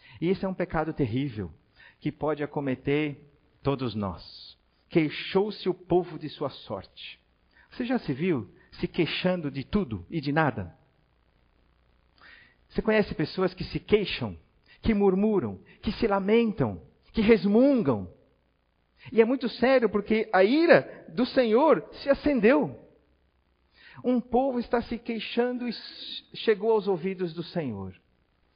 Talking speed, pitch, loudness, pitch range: 130 wpm, 180 Hz, -27 LUFS, 135-225 Hz